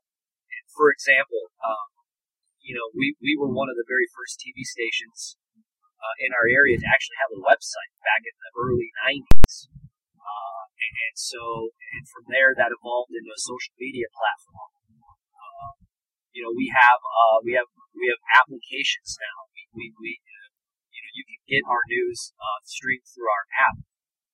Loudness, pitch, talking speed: -23 LUFS, 315 Hz, 175 wpm